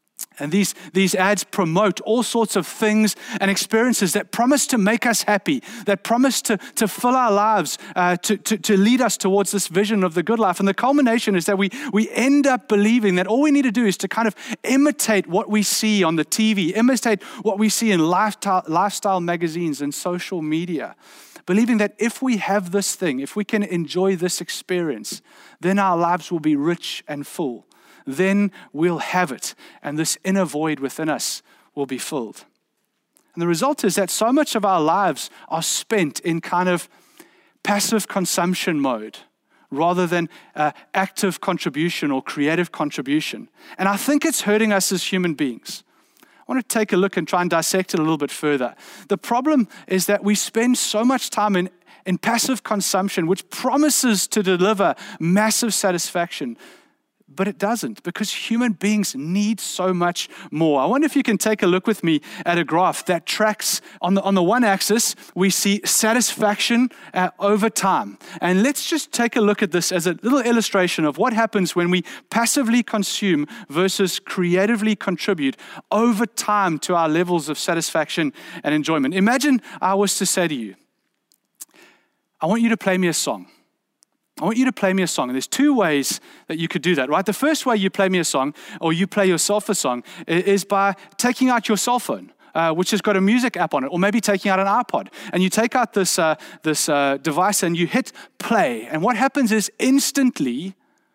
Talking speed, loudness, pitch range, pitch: 195 wpm, -20 LUFS, 180-230 Hz, 200 Hz